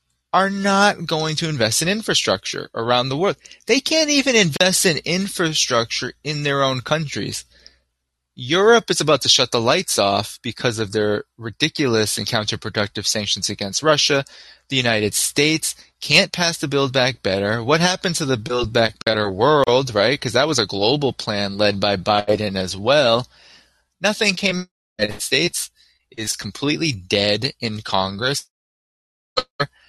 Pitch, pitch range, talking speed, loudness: 125 Hz, 105-165 Hz, 160 wpm, -19 LUFS